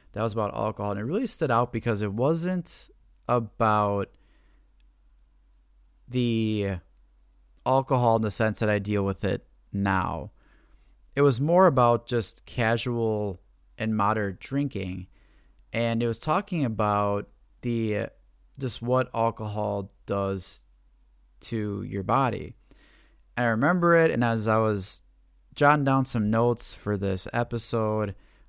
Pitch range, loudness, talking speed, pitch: 100-120 Hz, -26 LUFS, 130 wpm, 110 Hz